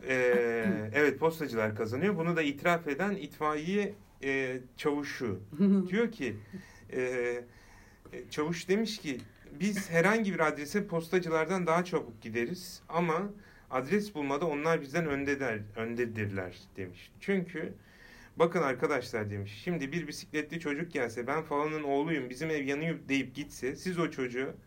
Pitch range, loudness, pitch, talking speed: 125-170 Hz, -32 LUFS, 145 Hz, 135 wpm